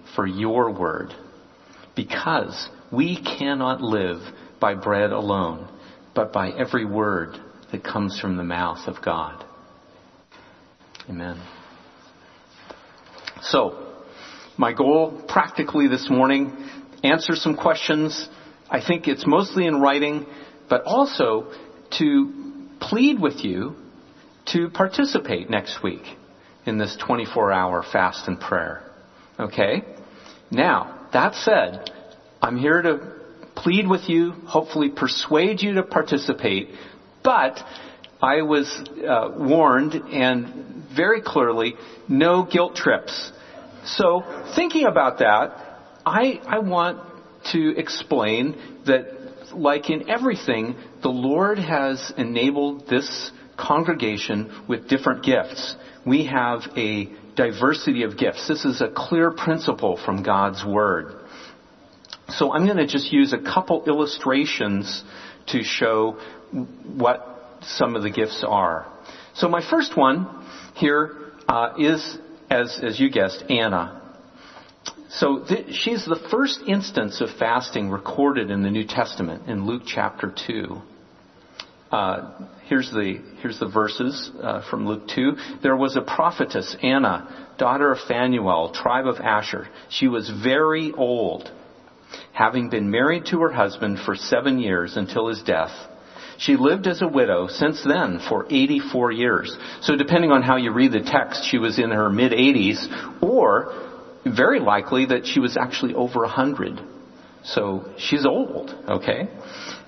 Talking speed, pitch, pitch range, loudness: 130 wpm, 140 Hz, 115-170 Hz, -22 LUFS